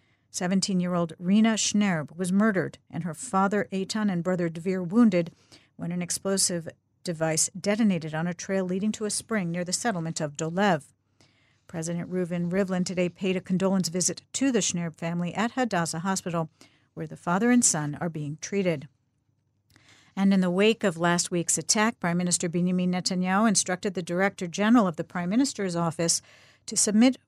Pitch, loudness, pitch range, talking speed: 180 Hz, -26 LUFS, 165-195 Hz, 170 wpm